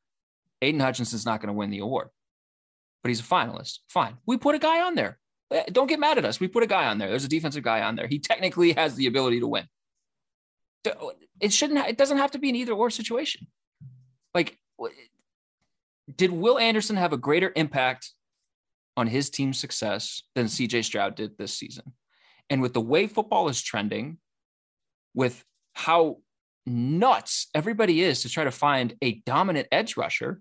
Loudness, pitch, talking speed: -25 LUFS, 145 Hz, 185 wpm